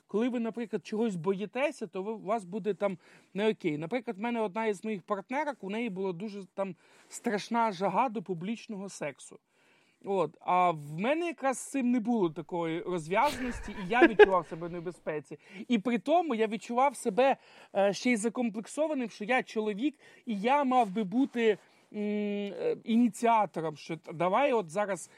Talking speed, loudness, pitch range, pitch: 160 wpm, -31 LUFS, 195-245 Hz, 220 Hz